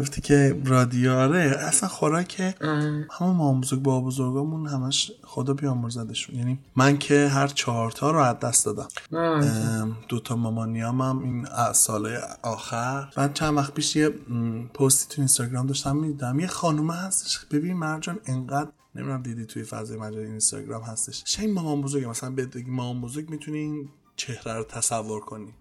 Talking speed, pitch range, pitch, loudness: 150 wpm, 120-150 Hz, 135 Hz, -25 LUFS